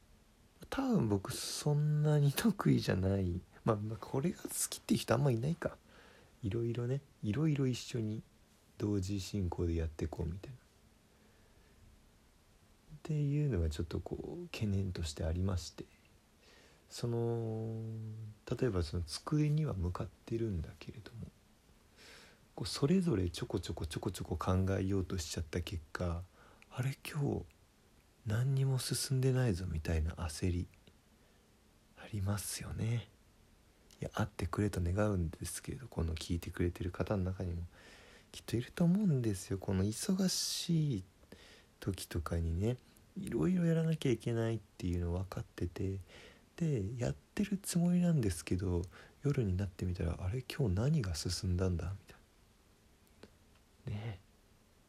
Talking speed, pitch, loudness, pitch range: 295 characters per minute, 105 Hz, -37 LUFS, 90-125 Hz